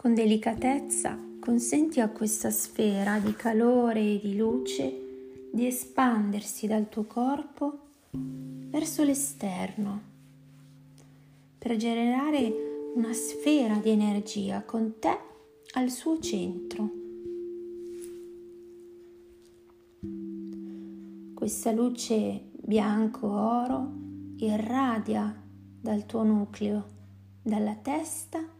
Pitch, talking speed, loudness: 215 Hz, 80 wpm, -29 LUFS